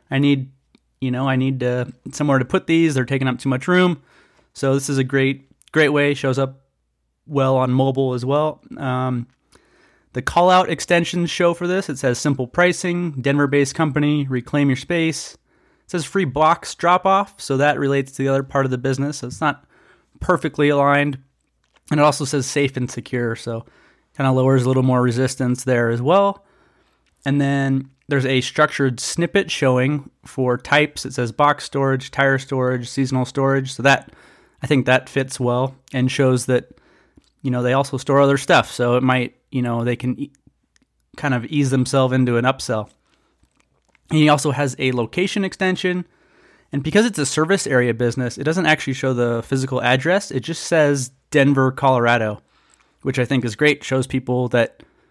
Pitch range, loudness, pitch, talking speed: 130-150 Hz, -19 LUFS, 135 Hz, 185 wpm